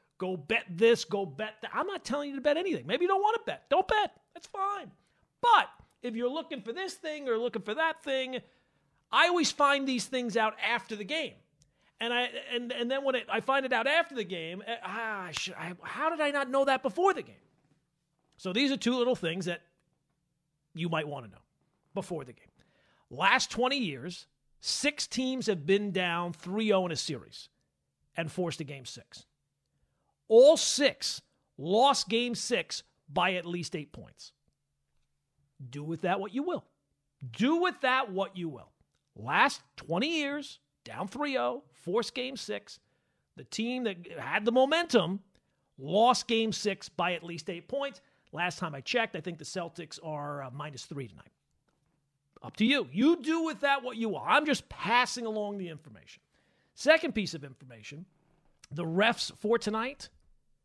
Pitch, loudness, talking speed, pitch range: 210 Hz, -30 LUFS, 180 wpm, 165-260 Hz